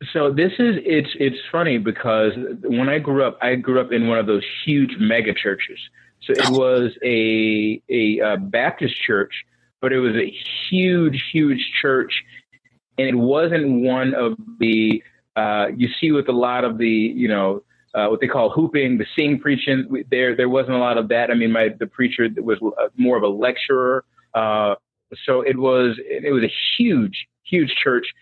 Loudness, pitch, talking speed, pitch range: -19 LUFS, 125 Hz, 185 wpm, 115-140 Hz